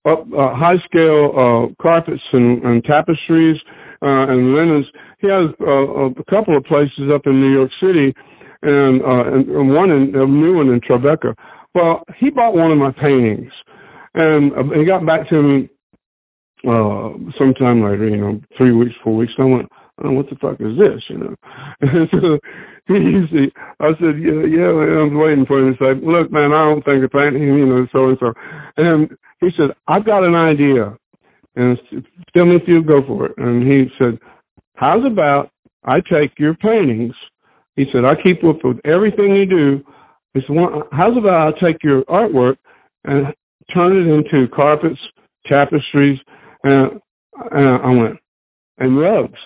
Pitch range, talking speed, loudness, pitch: 130-160 Hz, 180 wpm, -14 LUFS, 145 Hz